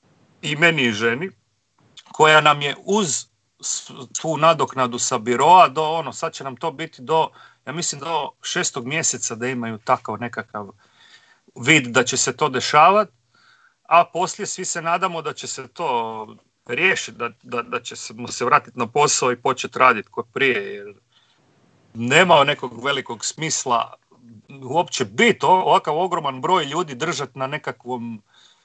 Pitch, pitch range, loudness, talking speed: 135 Hz, 120-165 Hz, -19 LUFS, 155 wpm